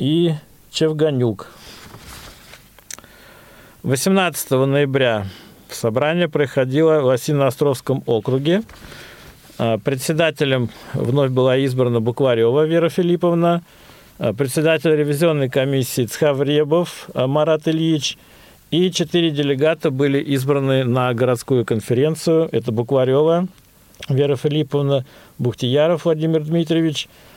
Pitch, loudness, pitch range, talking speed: 145 Hz, -18 LUFS, 130-160 Hz, 85 wpm